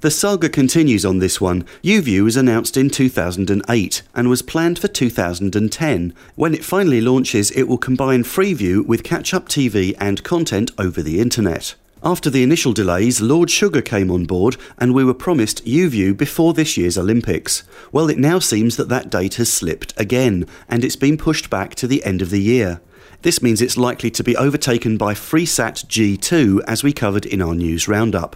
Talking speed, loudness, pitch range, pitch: 190 wpm, -17 LUFS, 100-145 Hz, 120 Hz